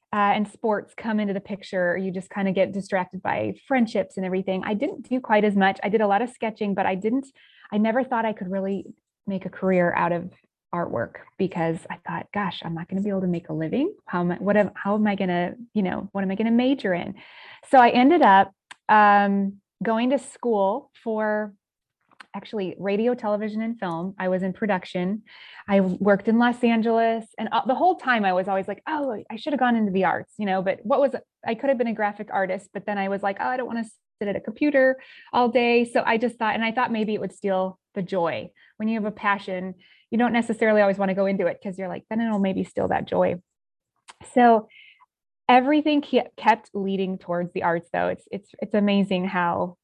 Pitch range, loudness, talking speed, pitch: 190-230 Hz, -24 LUFS, 235 wpm, 205 Hz